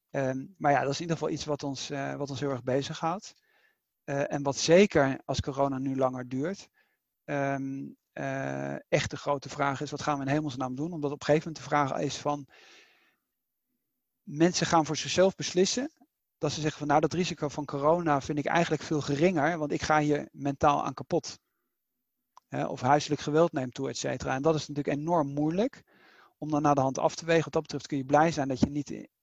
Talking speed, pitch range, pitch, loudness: 220 wpm, 140-160 Hz, 145 Hz, -29 LUFS